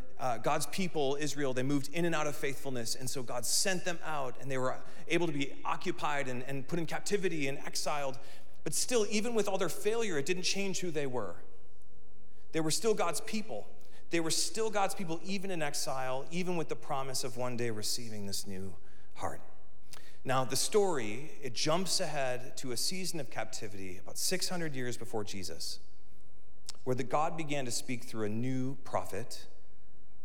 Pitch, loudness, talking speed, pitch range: 145 Hz, -35 LUFS, 185 wpm, 125-175 Hz